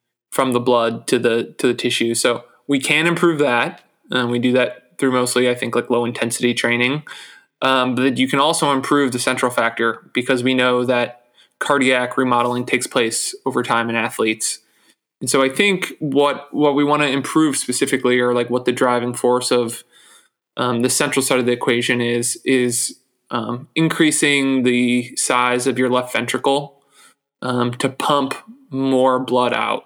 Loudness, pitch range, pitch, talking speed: -18 LUFS, 120-135 Hz, 125 Hz, 175 wpm